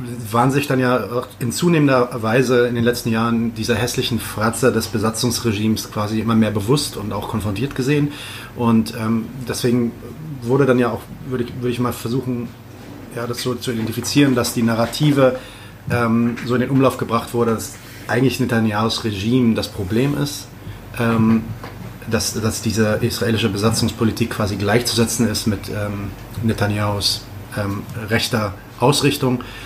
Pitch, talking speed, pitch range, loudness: 115 Hz, 150 wpm, 110-125 Hz, -19 LUFS